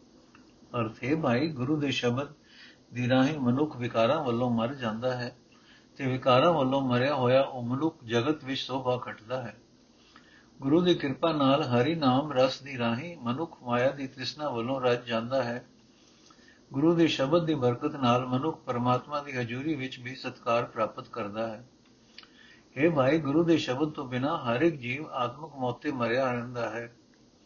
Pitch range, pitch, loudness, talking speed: 120-145 Hz, 130 Hz, -28 LUFS, 160 wpm